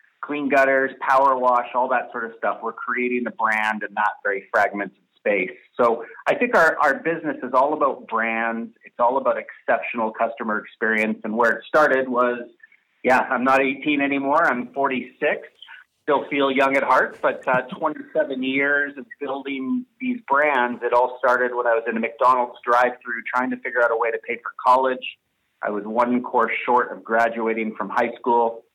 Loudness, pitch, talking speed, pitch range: -21 LUFS, 125 Hz, 185 wpm, 115-135 Hz